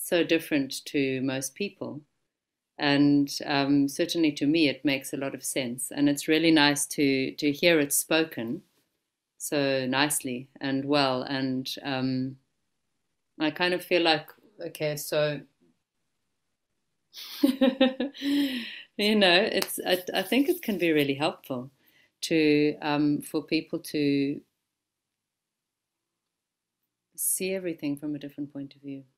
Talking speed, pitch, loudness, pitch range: 130 wpm, 150 Hz, -26 LUFS, 140-175 Hz